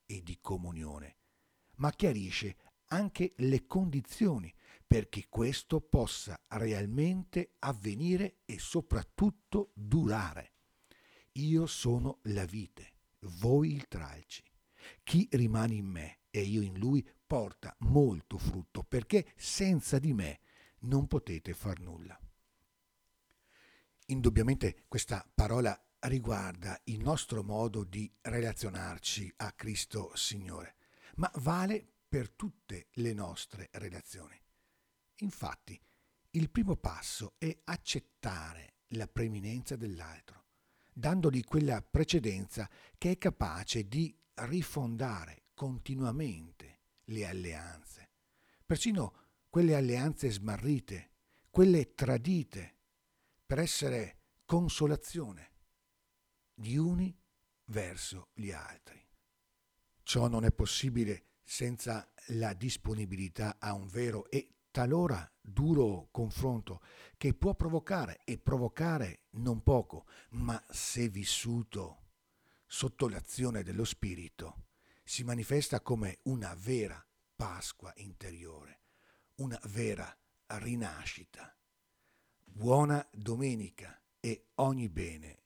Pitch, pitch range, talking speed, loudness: 115 Hz, 95-140 Hz, 95 wpm, -35 LUFS